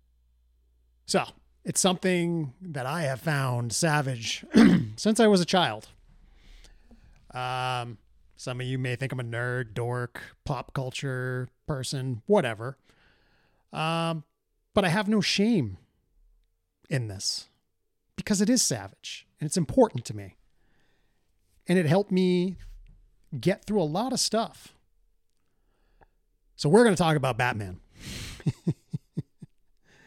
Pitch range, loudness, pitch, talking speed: 105-170 Hz, -27 LUFS, 130 Hz, 120 wpm